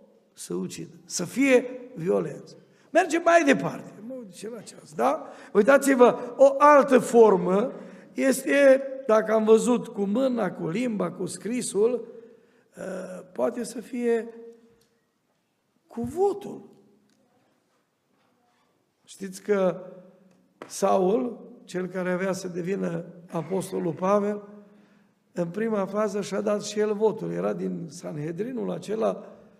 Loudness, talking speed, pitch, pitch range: -24 LUFS, 105 wpm, 210 Hz, 185-240 Hz